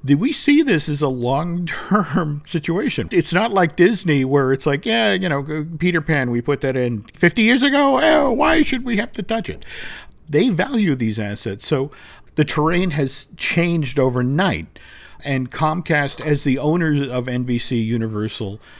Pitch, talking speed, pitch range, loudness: 150 Hz, 170 wpm, 135-180 Hz, -19 LUFS